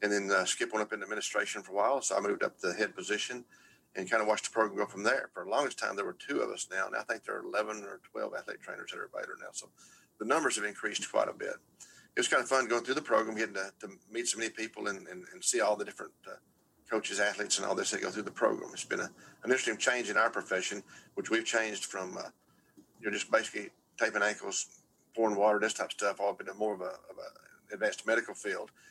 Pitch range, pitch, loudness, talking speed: 100-120 Hz, 110 Hz, -33 LUFS, 270 wpm